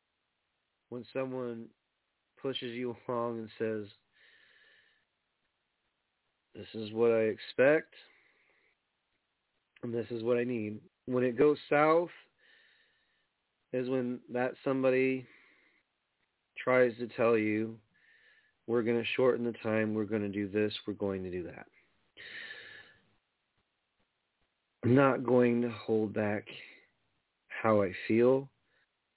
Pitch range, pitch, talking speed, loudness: 110-135 Hz, 120 Hz, 115 wpm, -31 LUFS